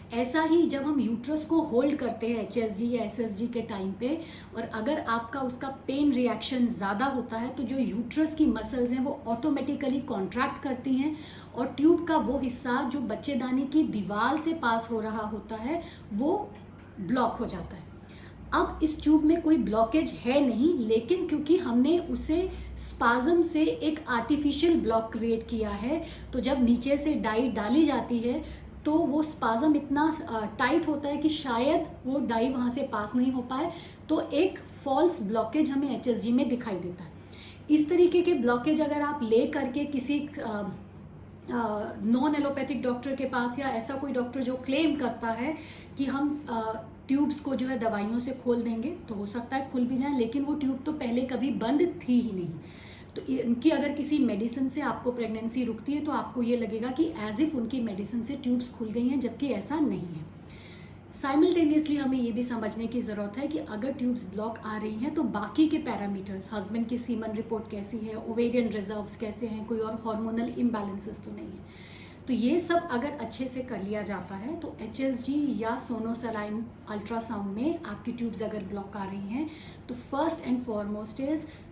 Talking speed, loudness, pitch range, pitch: 185 wpm, -29 LUFS, 225-290 Hz, 250 Hz